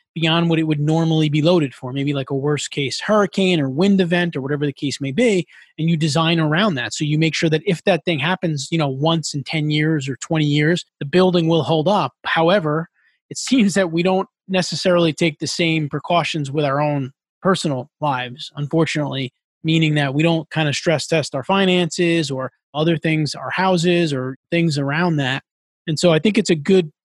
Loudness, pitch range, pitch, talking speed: -19 LUFS, 145-175 Hz, 160 Hz, 210 wpm